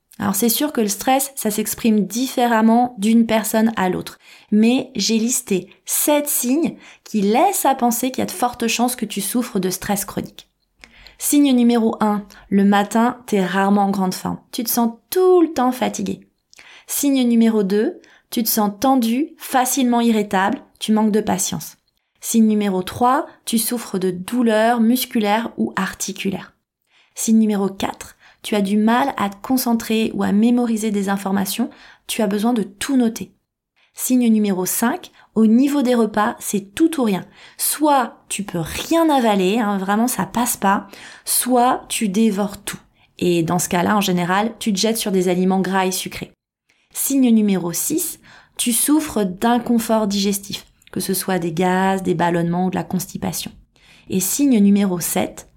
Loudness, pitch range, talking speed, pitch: -18 LUFS, 195-245 Hz, 170 wpm, 220 Hz